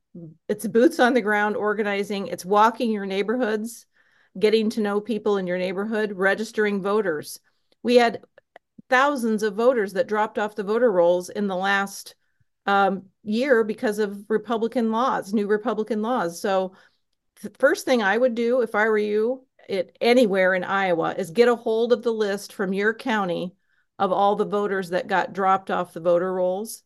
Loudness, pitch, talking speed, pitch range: -23 LUFS, 215 Hz, 175 wpm, 195-230 Hz